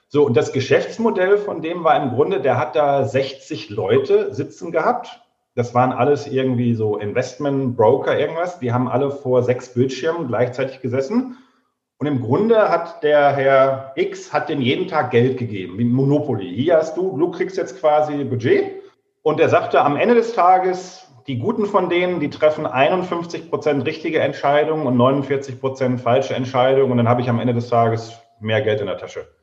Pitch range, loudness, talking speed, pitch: 125-185 Hz, -19 LUFS, 180 wpm, 140 Hz